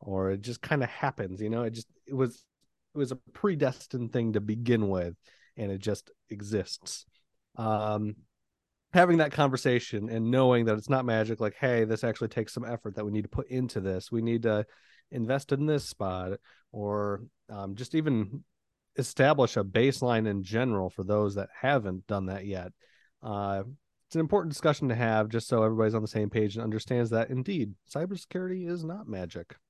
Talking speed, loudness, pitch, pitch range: 190 wpm, -30 LUFS, 115 Hz, 105-130 Hz